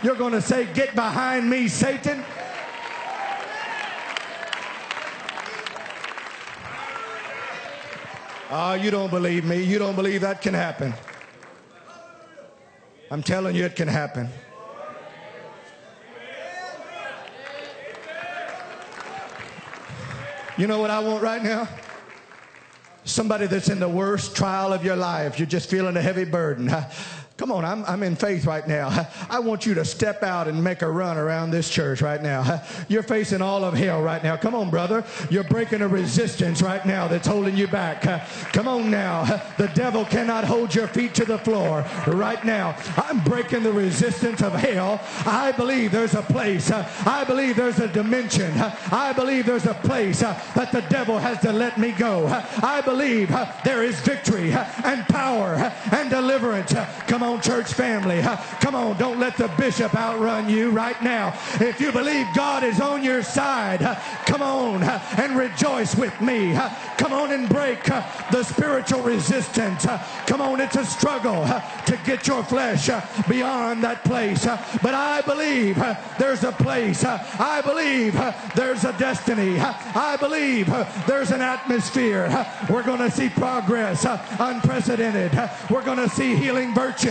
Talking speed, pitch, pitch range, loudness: 145 wpm, 220 Hz, 185-250 Hz, -23 LUFS